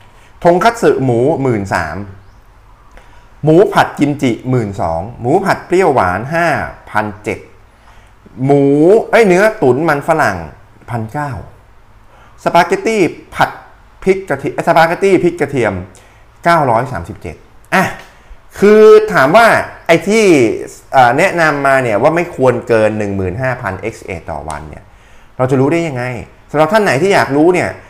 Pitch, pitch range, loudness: 125 Hz, 105-165 Hz, -12 LUFS